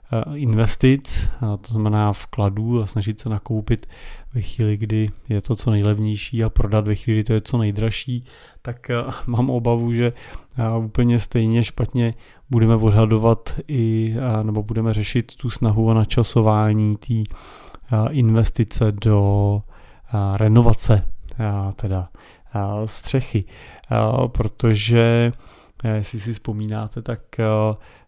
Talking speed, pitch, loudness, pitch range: 110 wpm, 110 Hz, -20 LUFS, 105-120 Hz